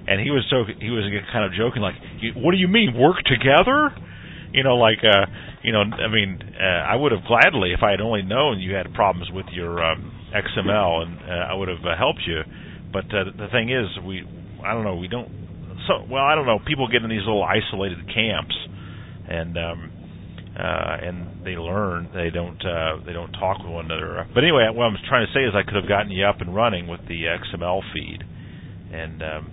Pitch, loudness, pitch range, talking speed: 95 Hz, -21 LUFS, 85-110 Hz, 225 wpm